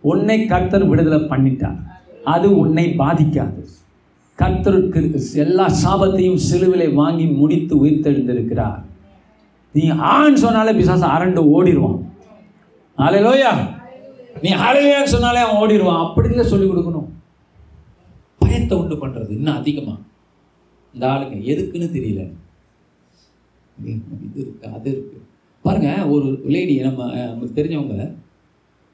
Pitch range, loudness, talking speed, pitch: 110-180 Hz, -16 LUFS, 100 wpm, 150 Hz